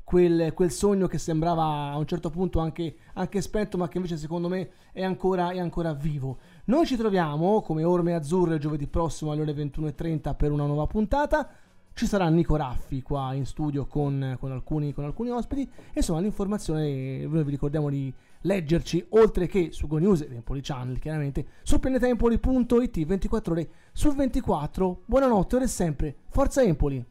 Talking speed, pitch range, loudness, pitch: 170 wpm, 150-200 Hz, -27 LUFS, 170 Hz